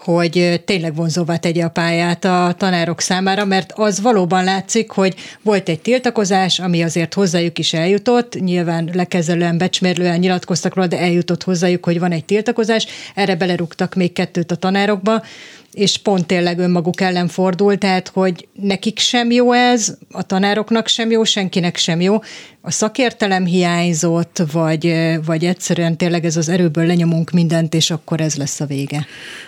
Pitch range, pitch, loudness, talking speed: 170-200 Hz, 180 Hz, -16 LUFS, 155 wpm